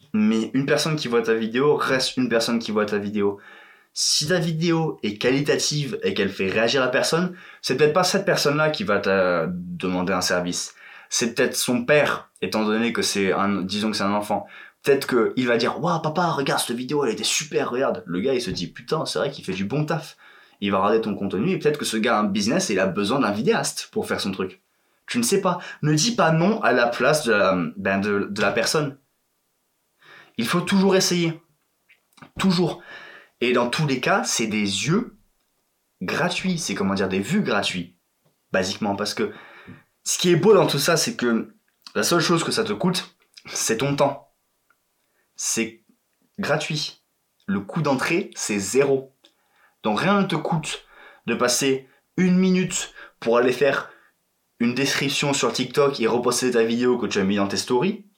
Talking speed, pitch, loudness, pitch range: 200 wpm, 140 Hz, -22 LUFS, 110-175 Hz